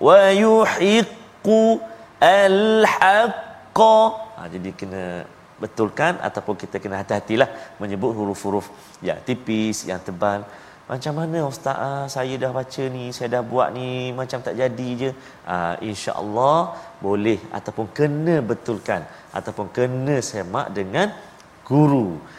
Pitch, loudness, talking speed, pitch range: 125 Hz, -21 LUFS, 115 wpm, 100-145 Hz